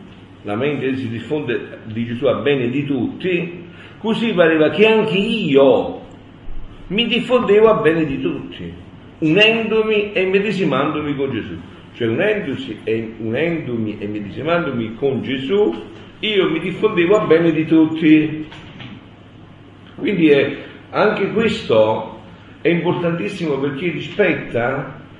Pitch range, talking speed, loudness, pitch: 115-185 Hz, 115 wpm, -17 LUFS, 150 Hz